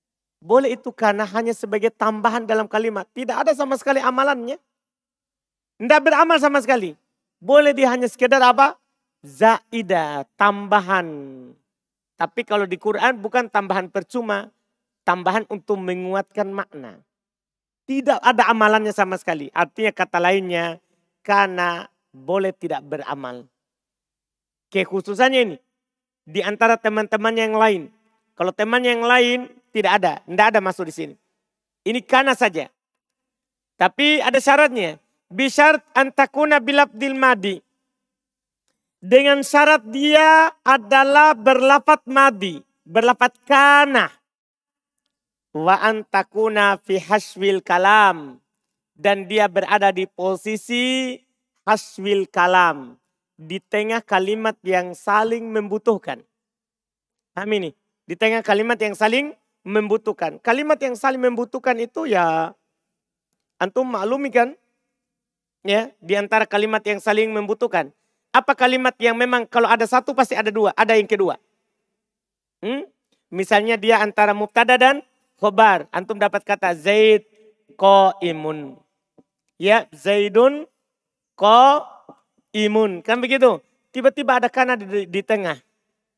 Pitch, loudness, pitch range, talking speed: 220 Hz, -18 LUFS, 195-255 Hz, 115 wpm